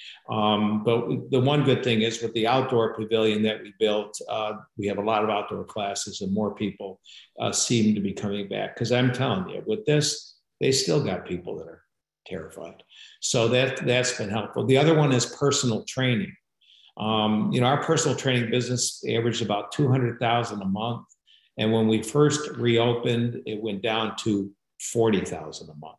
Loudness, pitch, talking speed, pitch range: -25 LUFS, 115 Hz, 190 wpm, 110-125 Hz